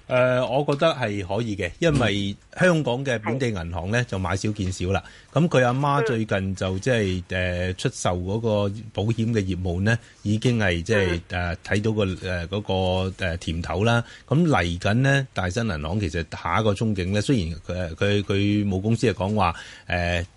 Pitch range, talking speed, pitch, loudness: 90-115 Hz, 270 characters per minute, 105 Hz, -24 LUFS